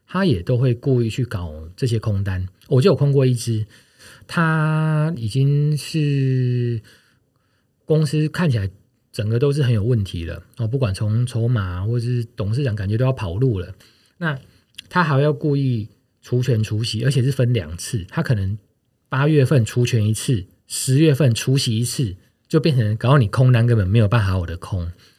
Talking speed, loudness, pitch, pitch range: 255 characters per minute, -20 LUFS, 120 Hz, 110-135 Hz